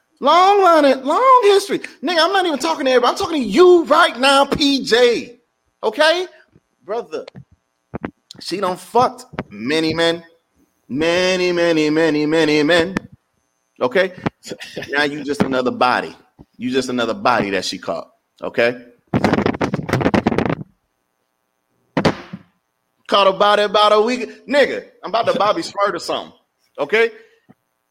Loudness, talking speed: -16 LUFS, 130 wpm